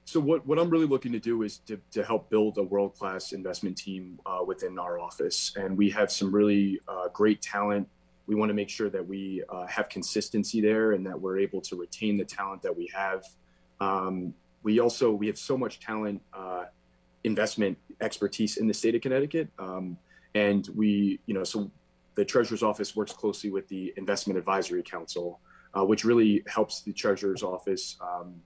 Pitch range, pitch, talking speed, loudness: 95-110 Hz, 100 Hz, 190 wpm, -29 LUFS